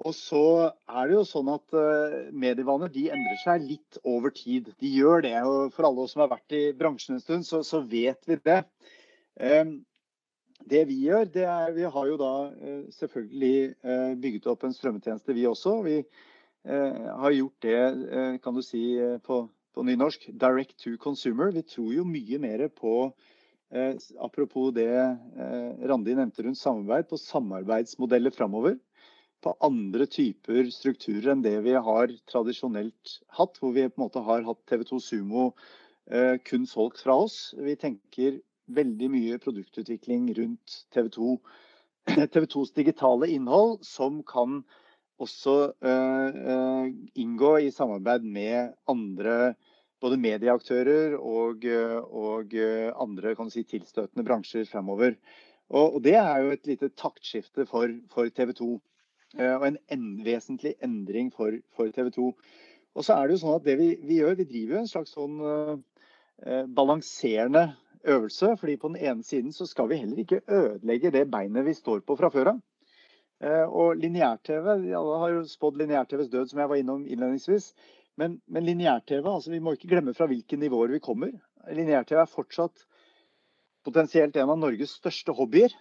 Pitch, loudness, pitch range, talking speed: 135 Hz, -27 LUFS, 120-160 Hz, 160 wpm